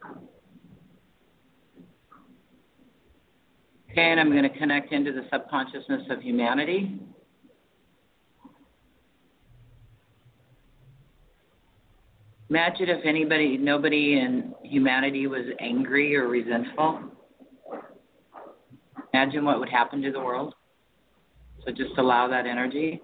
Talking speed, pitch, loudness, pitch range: 85 wpm, 135 Hz, -25 LUFS, 125-155 Hz